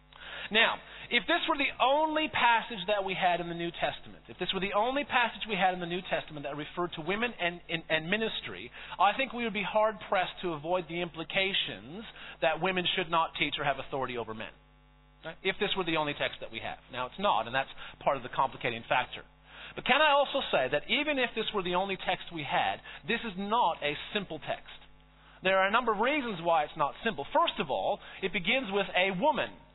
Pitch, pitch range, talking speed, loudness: 190 Hz, 165-230 Hz, 230 wpm, -30 LUFS